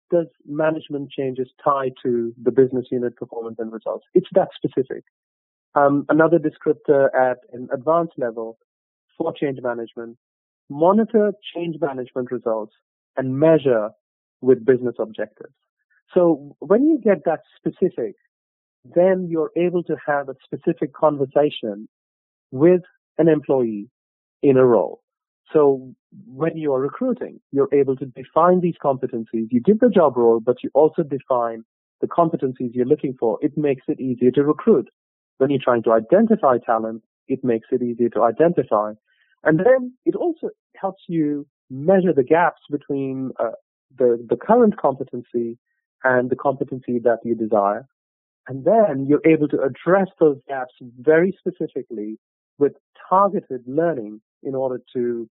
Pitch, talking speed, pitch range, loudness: 140 Hz, 145 wpm, 120-165 Hz, -20 LUFS